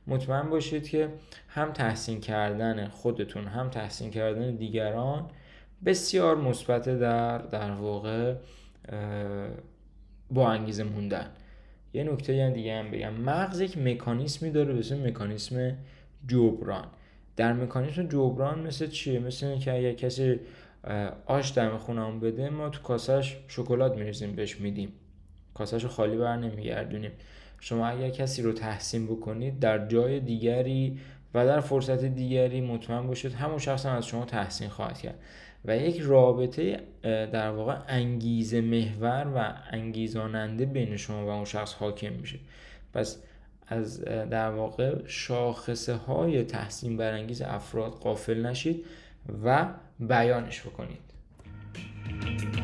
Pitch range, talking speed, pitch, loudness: 110-130 Hz, 125 wpm, 120 Hz, -30 LUFS